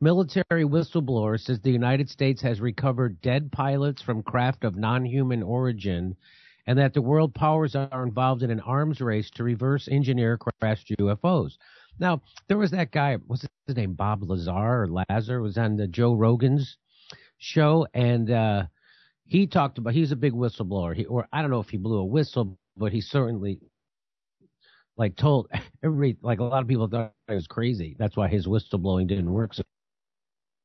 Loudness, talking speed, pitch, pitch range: -25 LUFS, 175 wpm, 120 Hz, 110-140 Hz